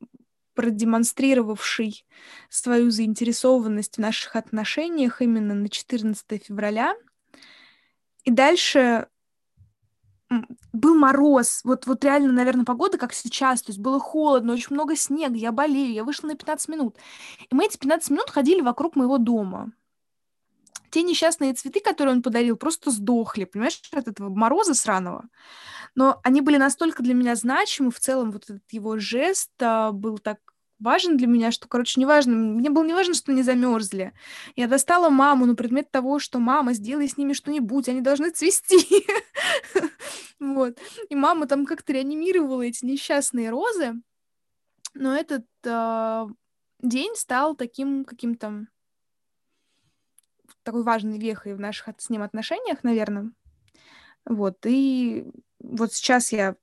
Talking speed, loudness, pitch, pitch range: 135 wpm, -22 LUFS, 255 Hz, 230-290 Hz